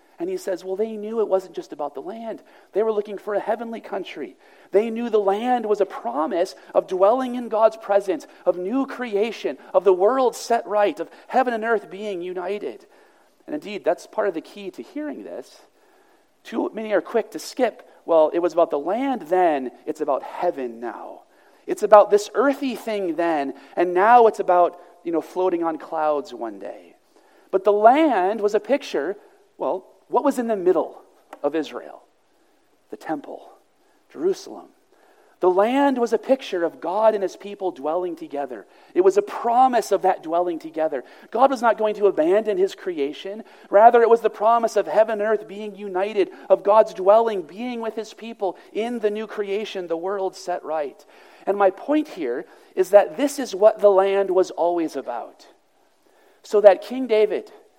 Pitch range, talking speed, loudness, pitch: 190-260 Hz, 185 wpm, -21 LUFS, 215 Hz